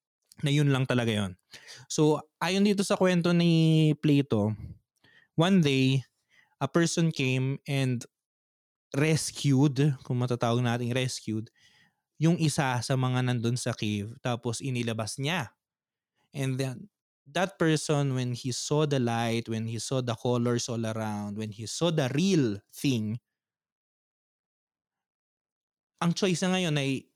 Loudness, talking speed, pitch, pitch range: -28 LUFS, 135 wpm, 130 Hz, 115-155 Hz